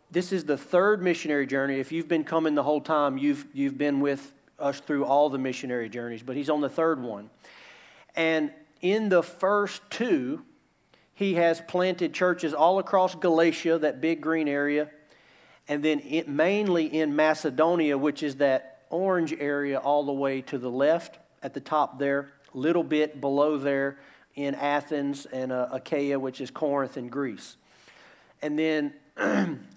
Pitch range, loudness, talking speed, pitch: 140-165 Hz, -27 LUFS, 165 wpm, 150 Hz